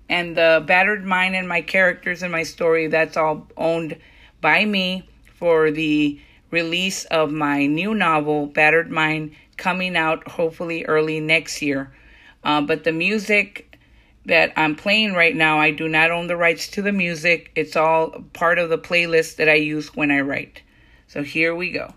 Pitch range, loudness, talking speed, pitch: 155-175 Hz, -19 LUFS, 175 wpm, 165 Hz